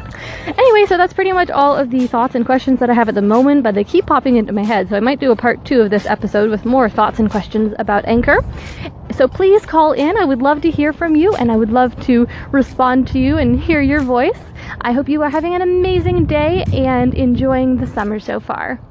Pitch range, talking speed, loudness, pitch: 230-300 Hz, 250 wpm, -14 LUFS, 260 Hz